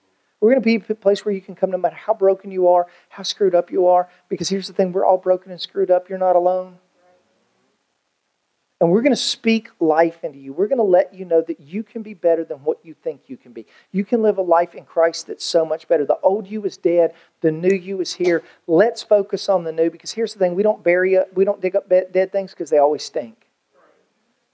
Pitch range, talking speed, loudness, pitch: 175-200 Hz, 255 wpm, -19 LUFS, 185 Hz